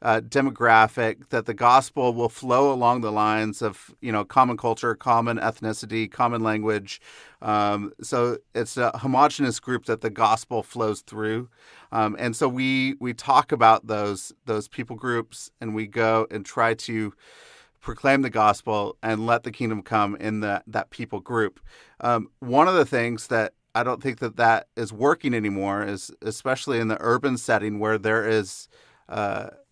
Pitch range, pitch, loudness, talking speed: 110-120 Hz, 115 Hz, -23 LUFS, 170 wpm